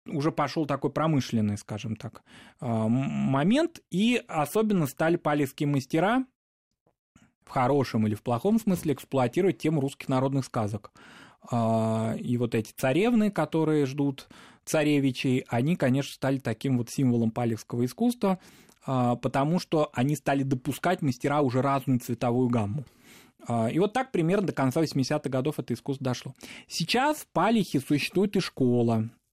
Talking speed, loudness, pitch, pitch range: 135 wpm, -27 LUFS, 140 Hz, 120-160 Hz